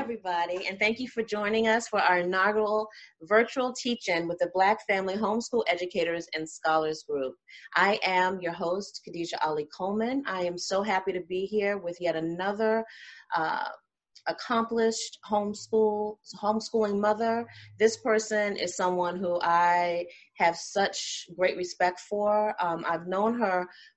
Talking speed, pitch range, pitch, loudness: 145 wpm, 175-215 Hz, 195 Hz, -28 LUFS